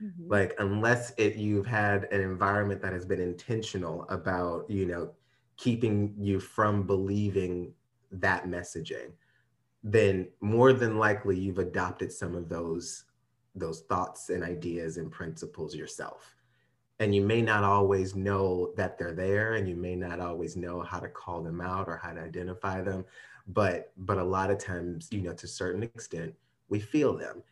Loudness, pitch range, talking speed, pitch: -30 LUFS, 90-105 Hz, 165 wpm, 95 Hz